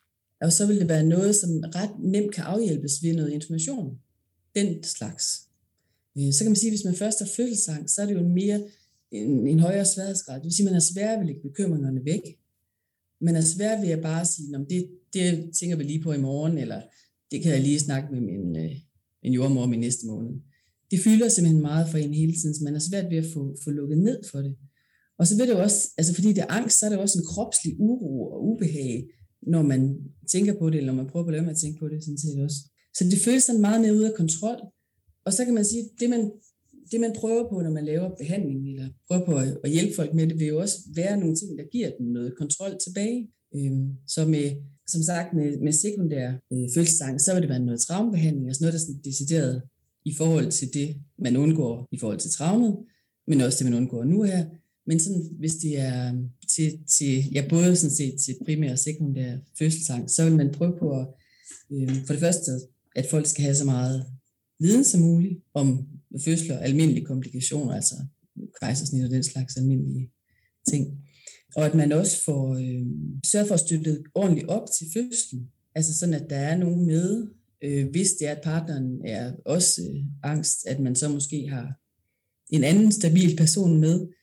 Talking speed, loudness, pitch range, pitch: 215 wpm, -24 LUFS, 135-180 Hz, 155 Hz